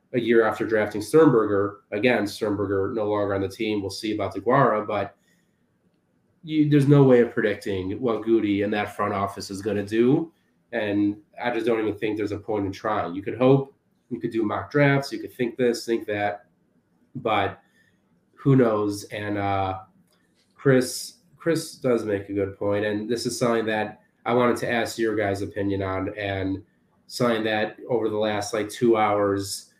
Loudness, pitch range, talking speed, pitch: -24 LUFS, 100-120 Hz, 185 wpm, 105 Hz